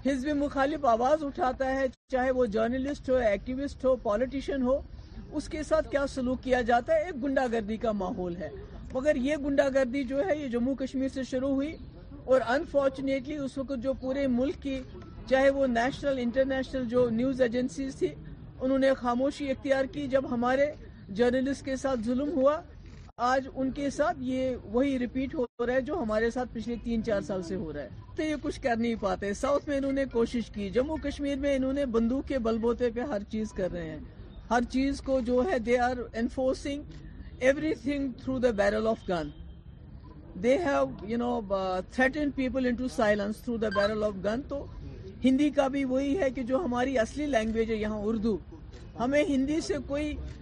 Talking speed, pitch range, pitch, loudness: 185 wpm, 235-275 Hz, 260 Hz, -29 LUFS